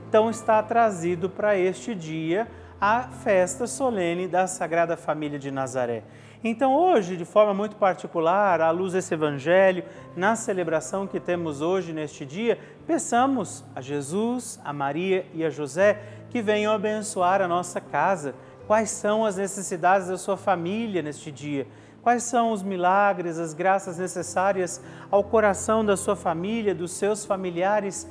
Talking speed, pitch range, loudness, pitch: 145 wpm, 170-210 Hz, -25 LUFS, 185 Hz